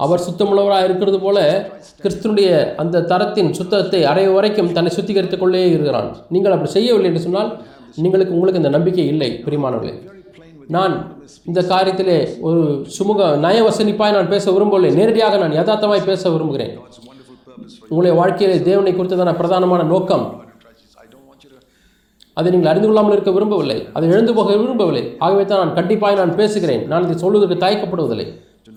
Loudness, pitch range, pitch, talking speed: -15 LUFS, 170-200 Hz, 185 Hz, 140 wpm